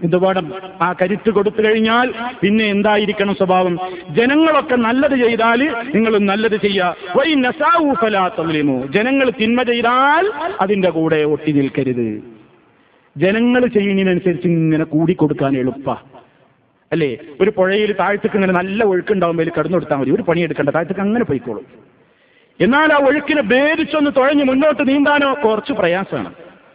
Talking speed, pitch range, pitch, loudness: 125 wpm, 175-250 Hz, 205 Hz, -15 LUFS